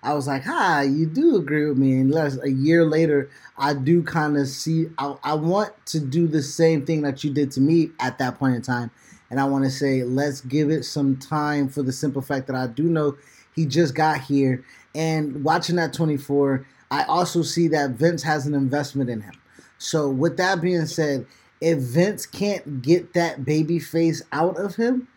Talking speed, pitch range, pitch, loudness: 205 wpm, 135-165 Hz, 150 Hz, -22 LUFS